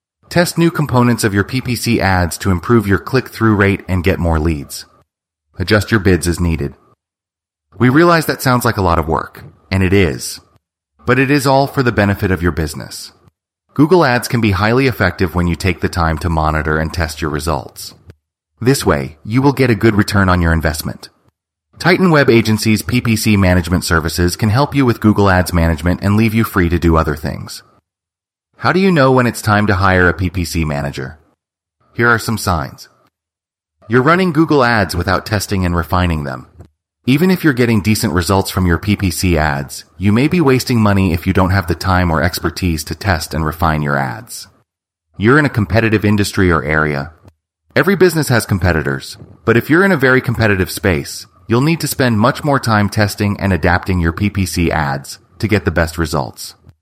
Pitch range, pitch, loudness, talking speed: 85-115 Hz, 95 Hz, -14 LUFS, 195 wpm